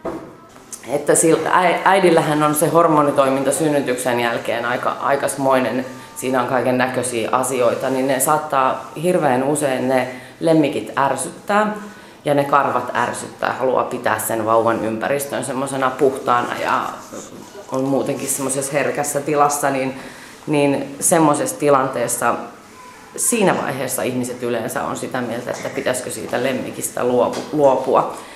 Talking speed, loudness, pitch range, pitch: 120 wpm, -18 LUFS, 125-145 Hz, 135 Hz